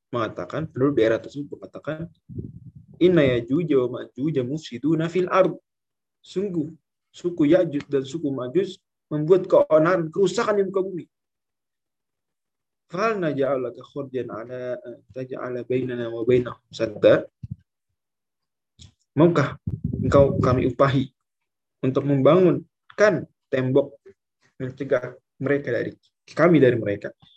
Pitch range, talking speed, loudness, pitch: 125-165 Hz, 105 wpm, -22 LUFS, 140 Hz